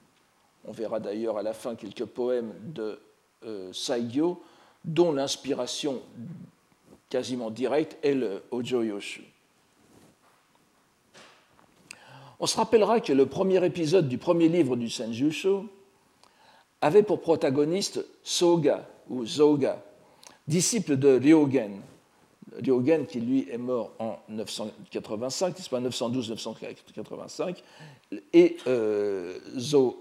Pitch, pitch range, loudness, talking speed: 155 Hz, 125-205 Hz, -27 LUFS, 100 wpm